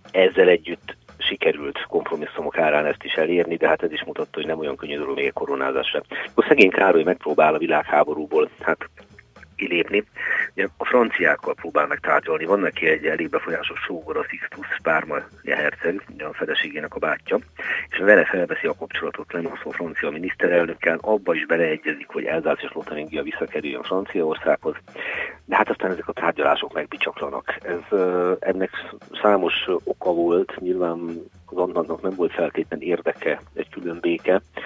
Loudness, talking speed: -22 LUFS, 150 wpm